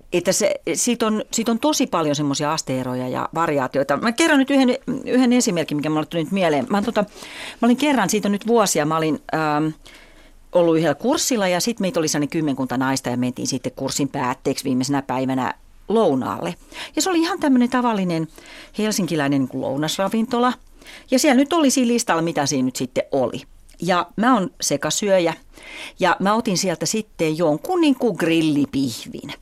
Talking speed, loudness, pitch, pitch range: 170 wpm, -20 LUFS, 185 Hz, 150-245 Hz